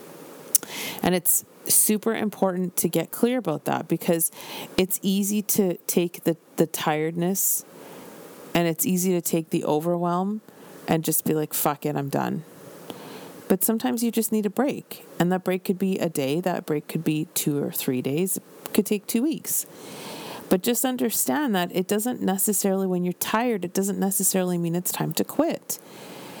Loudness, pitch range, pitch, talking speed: -24 LUFS, 170-215 Hz, 185 Hz, 175 wpm